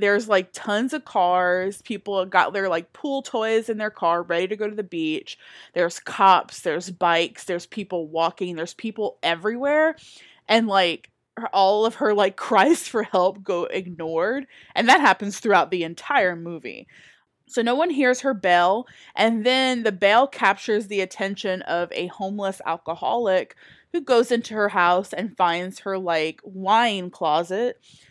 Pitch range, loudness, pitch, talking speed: 180-225 Hz, -22 LUFS, 195 Hz, 165 wpm